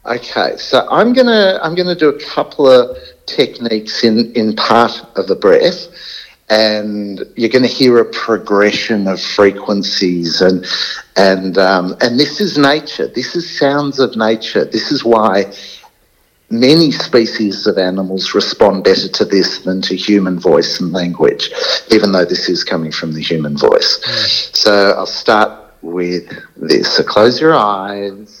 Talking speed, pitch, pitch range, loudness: 160 wpm, 110 Hz, 95-145 Hz, -12 LUFS